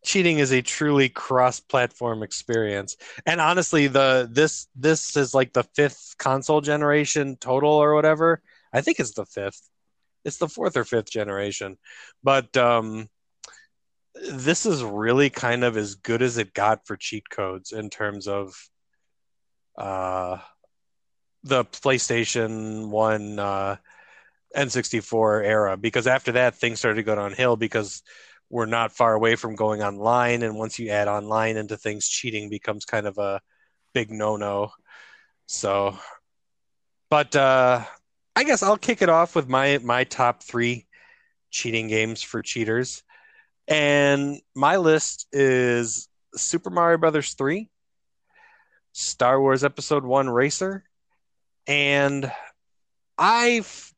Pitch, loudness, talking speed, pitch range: 120 Hz, -22 LUFS, 135 wpm, 110-145 Hz